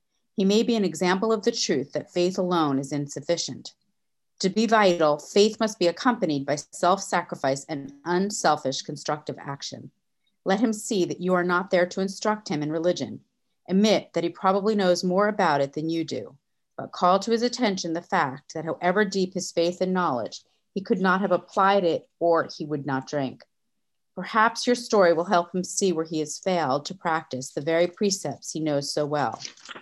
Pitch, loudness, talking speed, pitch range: 180 Hz, -25 LUFS, 195 wpm, 155-200 Hz